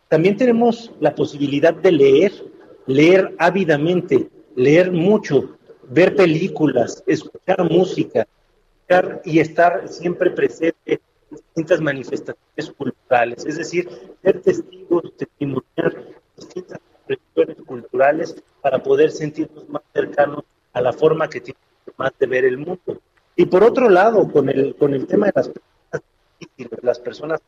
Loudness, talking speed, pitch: -18 LUFS, 130 wpm, 180 Hz